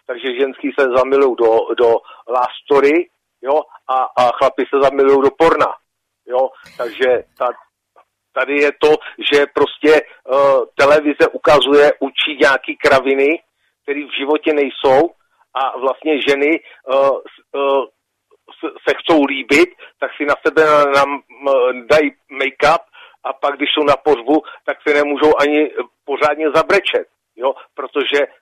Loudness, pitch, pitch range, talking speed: -15 LUFS, 150 Hz, 140-200 Hz, 135 wpm